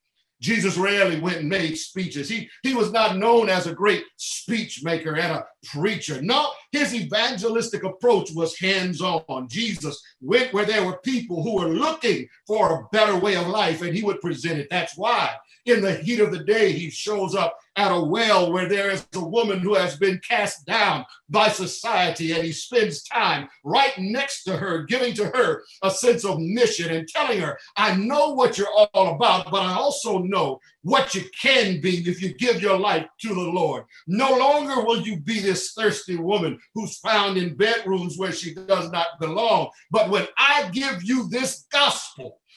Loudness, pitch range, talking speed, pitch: -22 LUFS, 180-230 Hz, 190 wpm, 200 Hz